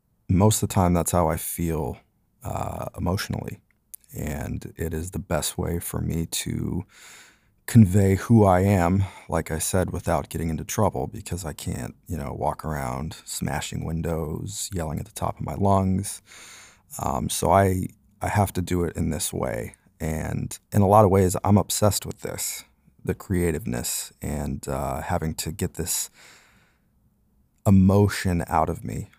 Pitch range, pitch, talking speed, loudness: 80-100 Hz, 90 Hz, 160 wpm, -24 LUFS